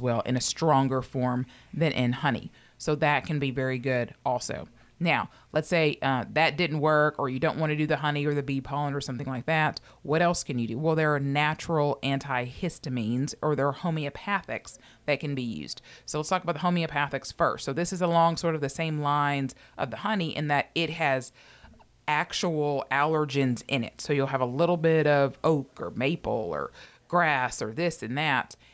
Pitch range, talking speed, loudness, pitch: 130-160 Hz, 205 wpm, -27 LUFS, 145 Hz